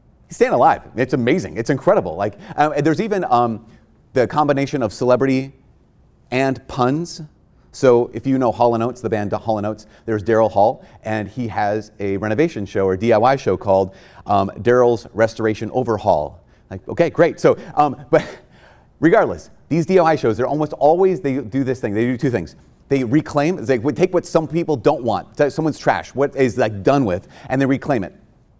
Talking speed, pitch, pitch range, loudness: 175 wpm, 125 Hz, 110-145 Hz, -18 LUFS